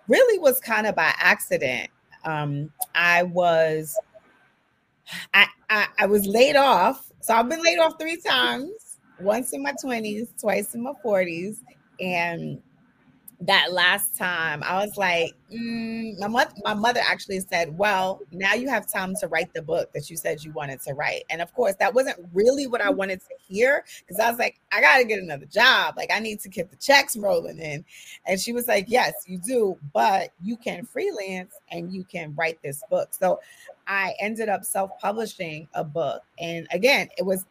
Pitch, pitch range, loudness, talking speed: 200 Hz, 175-240 Hz, -23 LUFS, 190 wpm